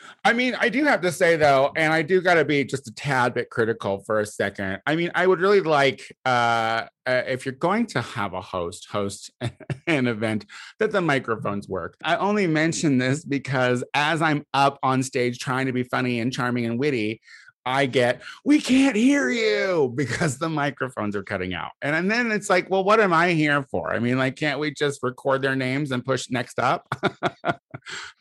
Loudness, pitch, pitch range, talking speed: -23 LUFS, 135 Hz, 120-165 Hz, 210 wpm